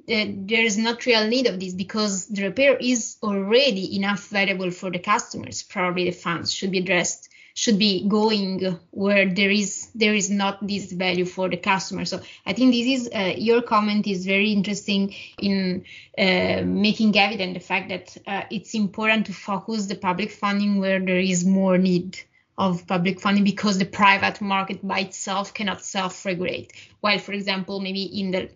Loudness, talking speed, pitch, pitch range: -22 LUFS, 180 wpm, 195 Hz, 185-210 Hz